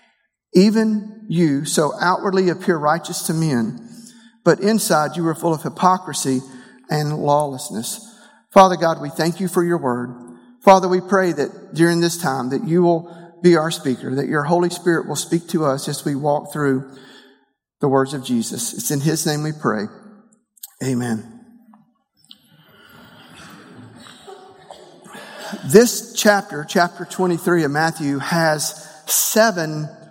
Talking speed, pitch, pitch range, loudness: 140 wpm, 170 Hz, 150-195 Hz, -18 LUFS